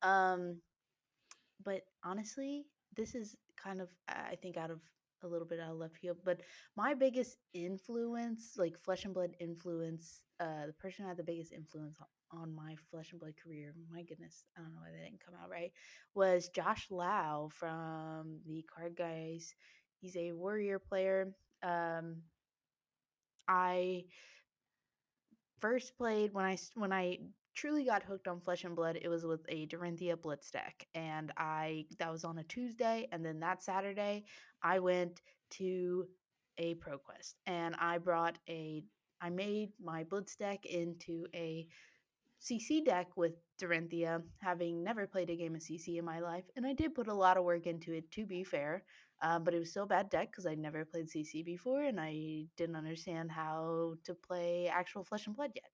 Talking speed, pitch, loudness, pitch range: 180 wpm, 175 Hz, -40 LUFS, 165-195 Hz